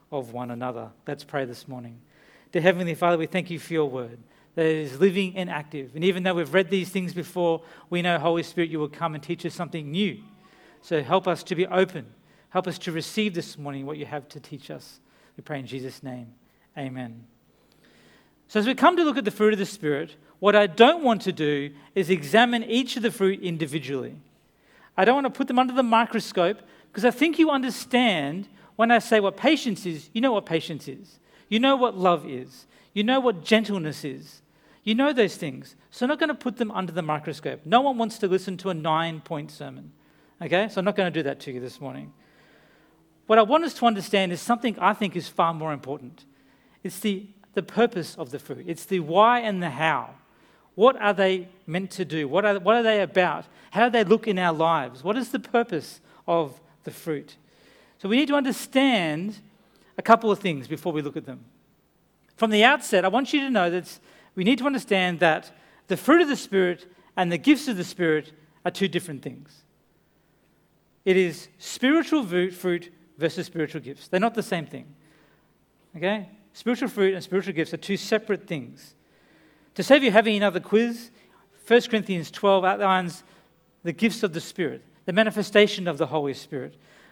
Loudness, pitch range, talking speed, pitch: -24 LUFS, 160-215 Hz, 205 wpm, 185 Hz